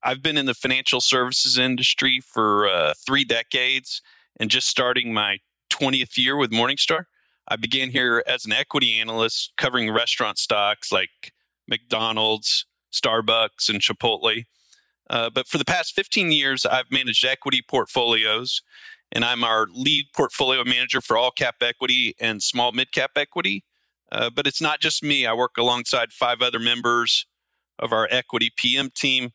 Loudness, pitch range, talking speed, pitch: -21 LUFS, 115-140 Hz, 155 wpm, 125 Hz